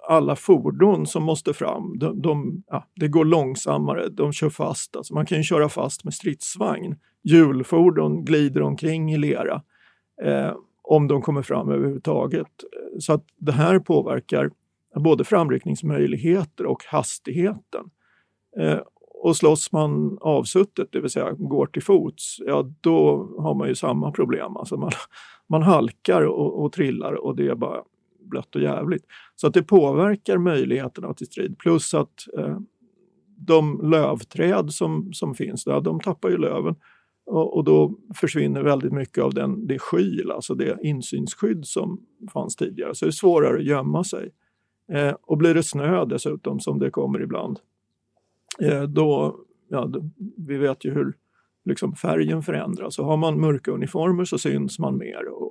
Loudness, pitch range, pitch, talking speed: -22 LUFS, 135-185 Hz, 155 Hz, 160 wpm